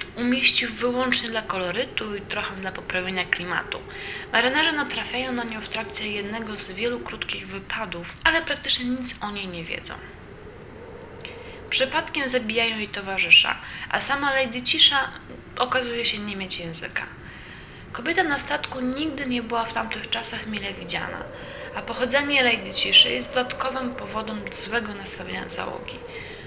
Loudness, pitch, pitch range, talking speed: -23 LUFS, 240 Hz, 210-275 Hz, 140 wpm